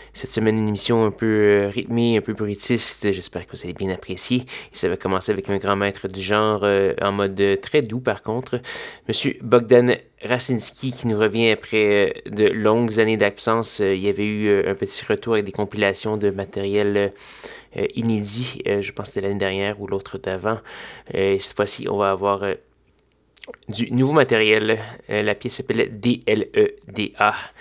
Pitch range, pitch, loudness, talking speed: 100-115 Hz, 105 Hz, -21 LUFS, 200 wpm